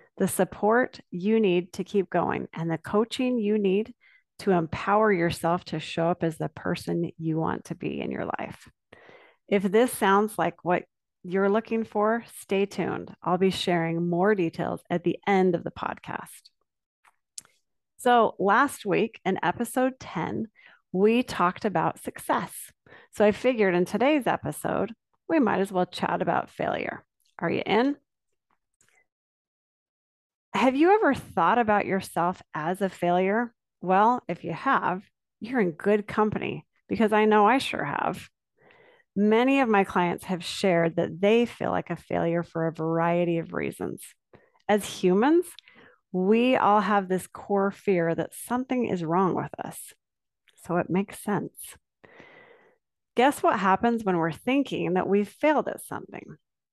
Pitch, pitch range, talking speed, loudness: 200 Hz, 175-230 Hz, 150 wpm, -26 LUFS